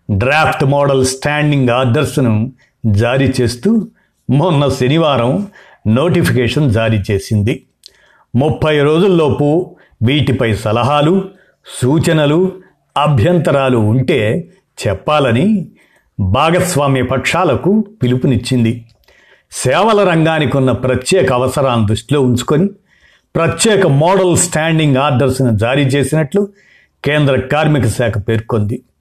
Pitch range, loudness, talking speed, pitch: 125-160 Hz, -13 LUFS, 80 wpm, 140 Hz